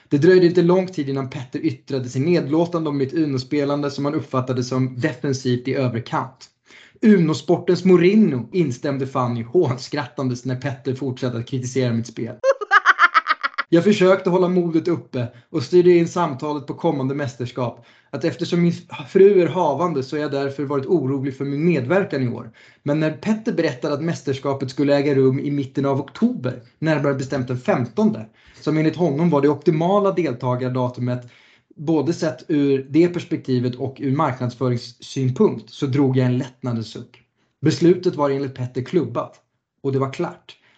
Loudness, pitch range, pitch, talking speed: -20 LUFS, 130-170 Hz, 145 Hz, 155 wpm